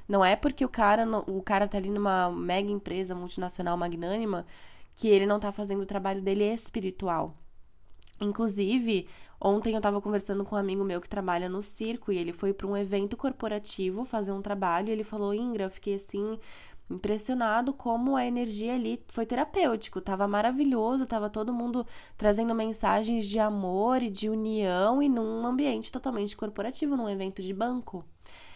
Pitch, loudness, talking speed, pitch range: 205 Hz, -30 LUFS, 170 wpm, 195-230 Hz